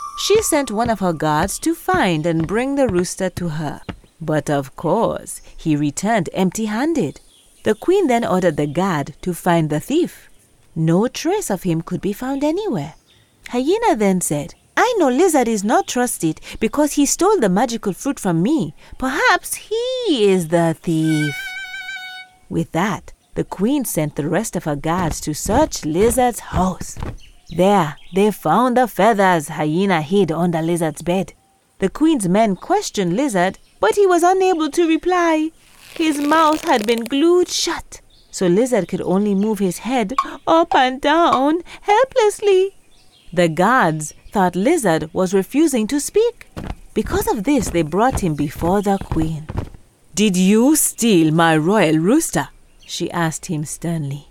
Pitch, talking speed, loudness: 205 Hz, 155 wpm, -18 LUFS